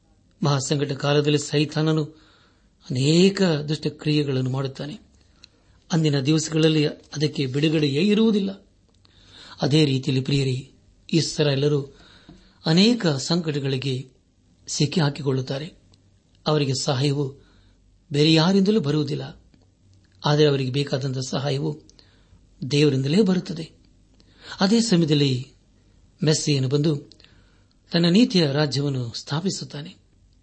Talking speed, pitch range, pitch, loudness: 75 wpm, 100-155 Hz, 145 Hz, -22 LUFS